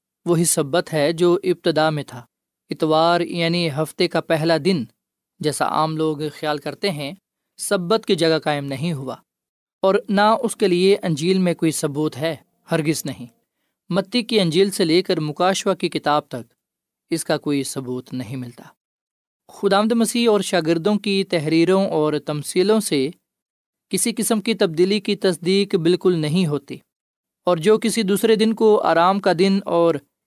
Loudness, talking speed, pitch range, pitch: -20 LUFS, 160 wpm, 155-195 Hz, 175 Hz